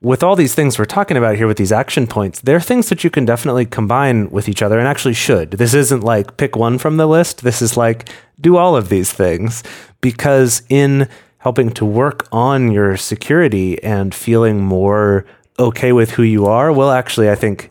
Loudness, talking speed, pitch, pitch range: -14 LUFS, 205 wpm, 120 Hz, 105-140 Hz